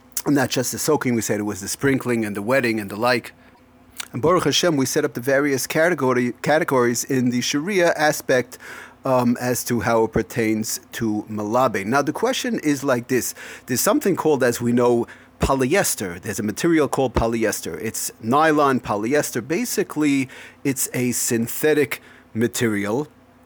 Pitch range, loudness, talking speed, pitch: 115-145 Hz, -21 LUFS, 165 wpm, 125 Hz